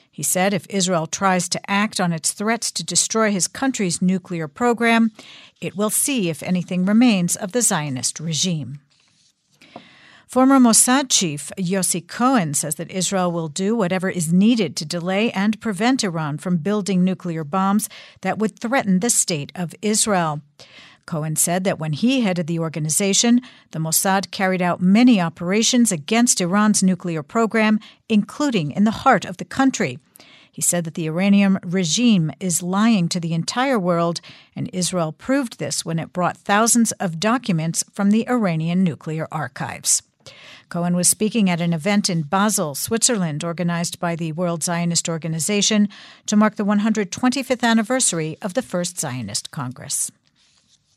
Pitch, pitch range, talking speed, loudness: 185 Hz, 170-215 Hz, 155 wpm, -19 LUFS